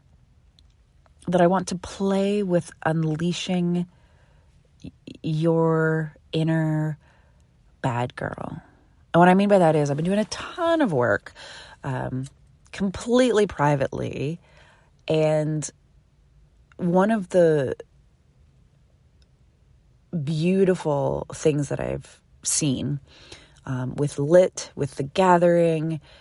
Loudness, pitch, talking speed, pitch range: -23 LUFS, 160 Hz, 100 wpm, 135-180 Hz